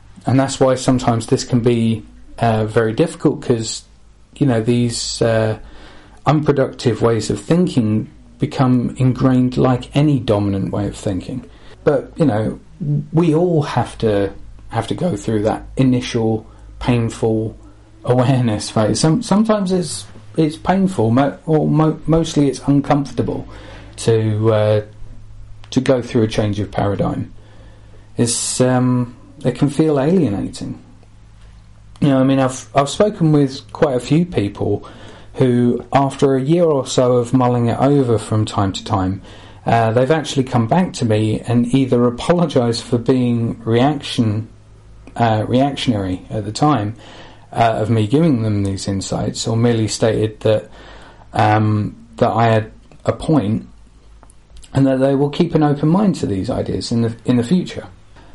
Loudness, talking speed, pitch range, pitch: -17 LUFS, 150 wpm, 110-135 Hz, 120 Hz